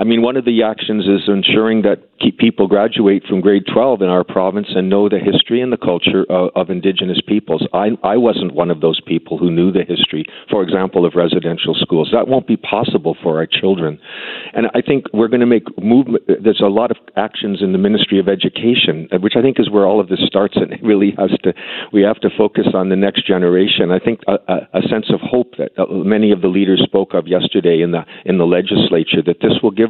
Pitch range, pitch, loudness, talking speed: 95-115 Hz, 100 Hz, -14 LUFS, 235 wpm